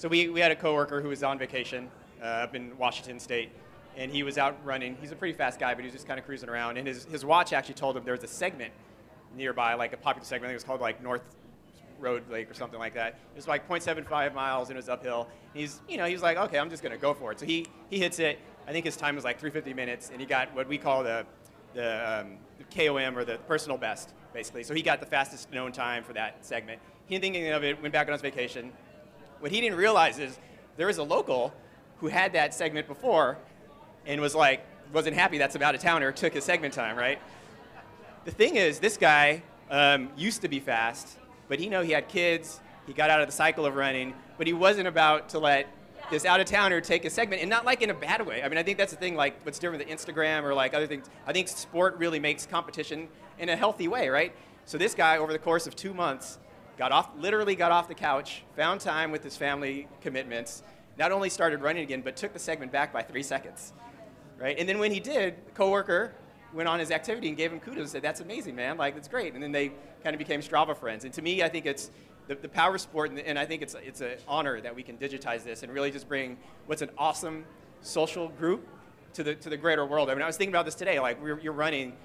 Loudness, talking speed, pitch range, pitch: -29 LUFS, 255 wpm, 130-165 Hz, 150 Hz